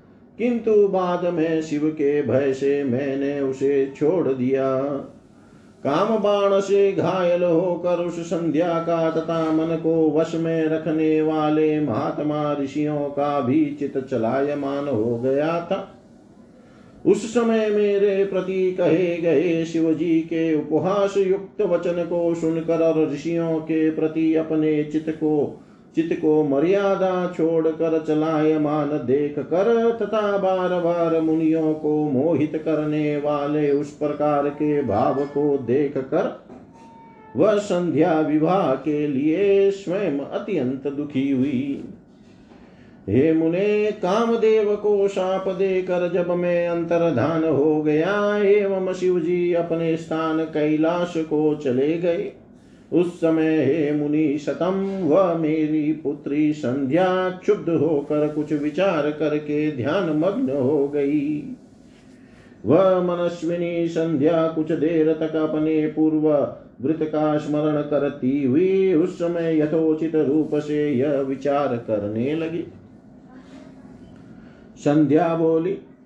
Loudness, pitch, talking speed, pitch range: -21 LUFS, 160 Hz, 120 wpm, 150-180 Hz